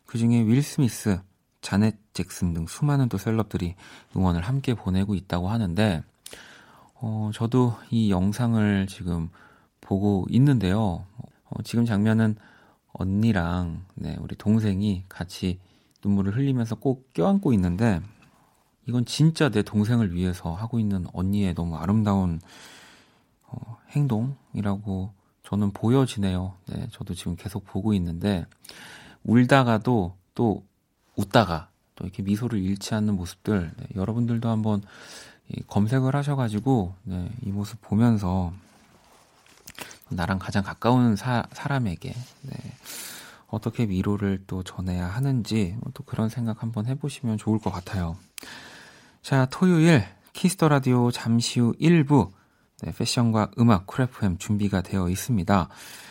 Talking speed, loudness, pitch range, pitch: 265 characters per minute, -25 LUFS, 95-120 Hz, 105 Hz